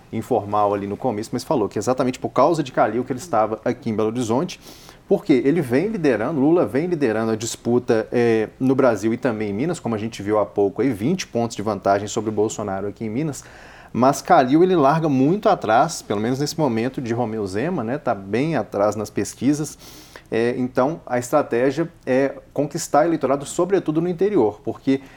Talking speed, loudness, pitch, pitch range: 200 wpm, -21 LUFS, 120 Hz, 110-135 Hz